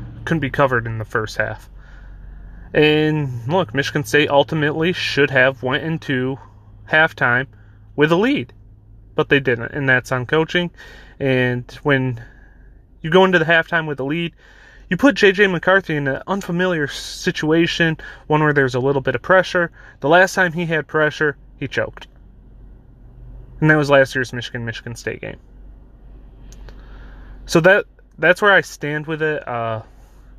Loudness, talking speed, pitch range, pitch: -18 LUFS, 155 wpm, 125-160 Hz, 140 Hz